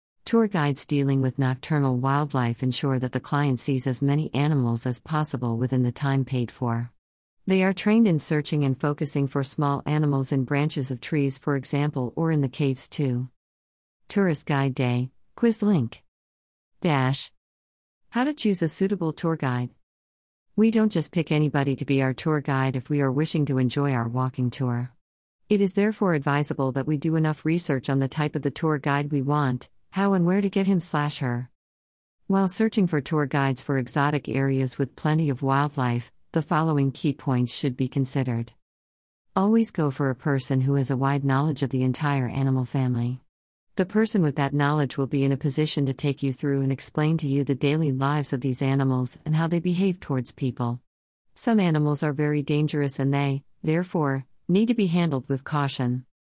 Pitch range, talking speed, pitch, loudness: 130-155 Hz, 190 wpm, 140 Hz, -25 LUFS